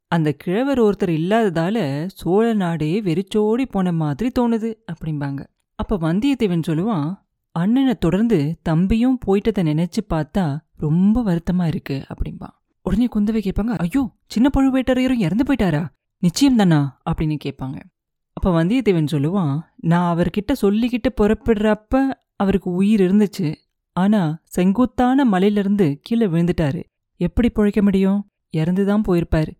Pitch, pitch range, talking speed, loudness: 195 Hz, 165-225 Hz, 115 wpm, -19 LUFS